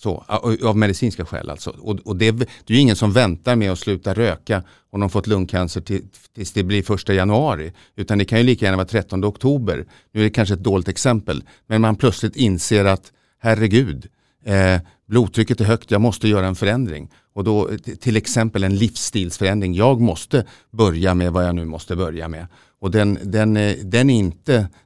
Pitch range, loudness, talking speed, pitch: 95-115 Hz, -19 LUFS, 205 wpm, 105 Hz